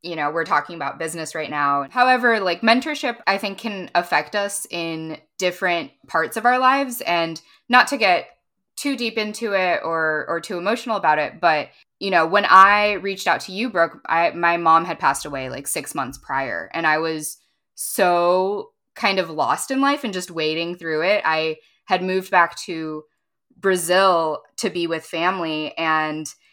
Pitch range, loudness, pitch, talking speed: 160-205 Hz, -20 LUFS, 175 Hz, 185 wpm